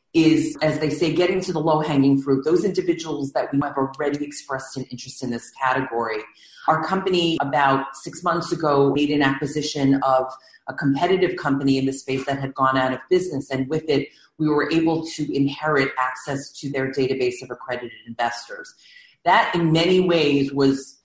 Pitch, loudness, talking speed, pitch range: 140 Hz, -22 LUFS, 185 wpm, 135-165 Hz